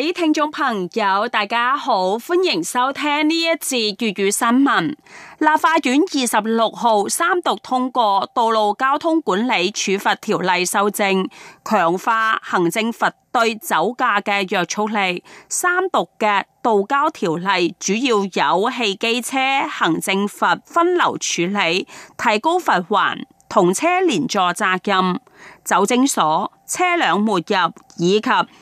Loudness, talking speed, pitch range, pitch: -18 LUFS, 195 characters per minute, 200-295 Hz, 225 Hz